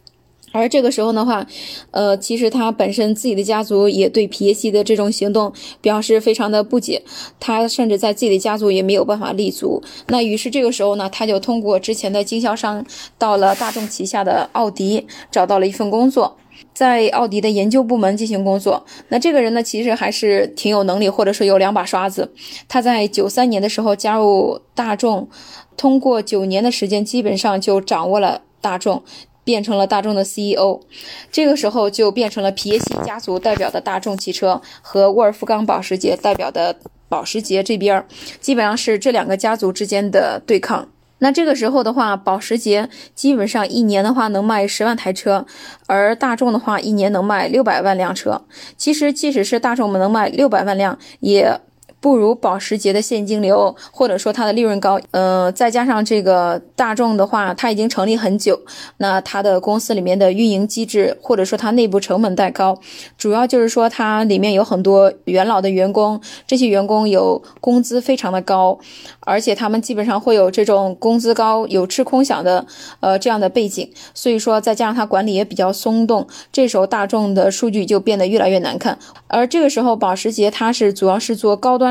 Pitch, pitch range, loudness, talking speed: 215 Hz, 195-235 Hz, -16 LUFS, 300 characters per minute